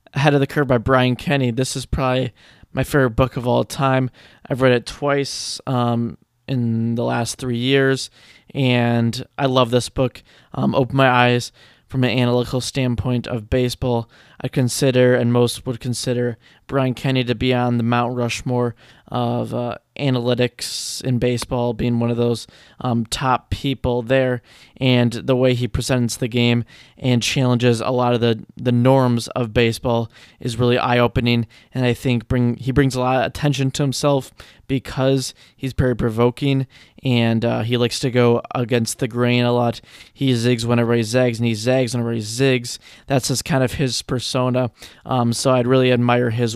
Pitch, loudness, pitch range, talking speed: 125 Hz, -19 LUFS, 120-130 Hz, 180 wpm